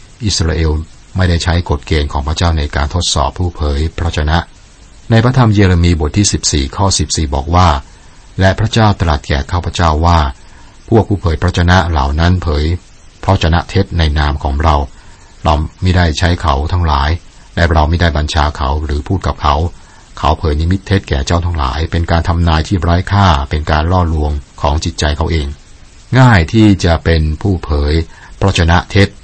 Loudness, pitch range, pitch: -13 LUFS, 75-95 Hz, 85 Hz